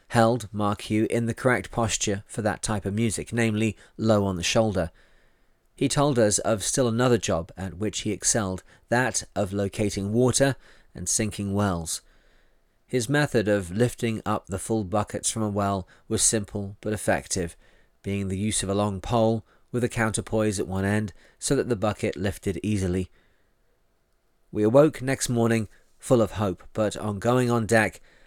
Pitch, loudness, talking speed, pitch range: 105 Hz, -25 LUFS, 170 wpm, 100-115 Hz